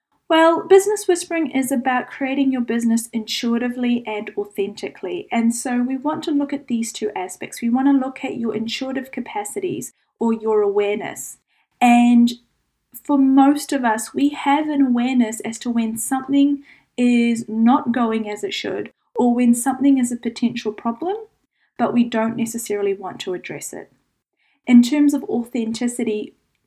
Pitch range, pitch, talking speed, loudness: 230-275 Hz, 240 Hz, 160 wpm, -20 LUFS